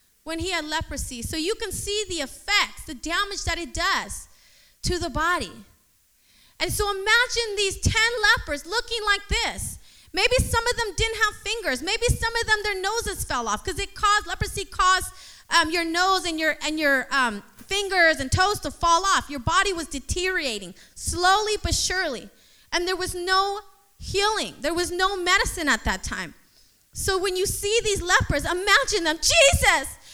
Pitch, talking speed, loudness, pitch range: 380 Hz, 175 wpm, -23 LUFS, 335-415 Hz